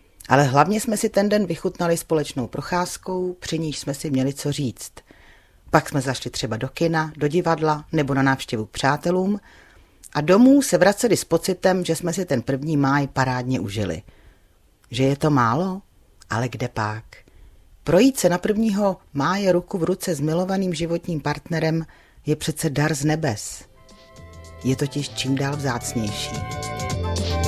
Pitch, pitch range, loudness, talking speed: 145 Hz, 125-175 Hz, -22 LUFS, 155 wpm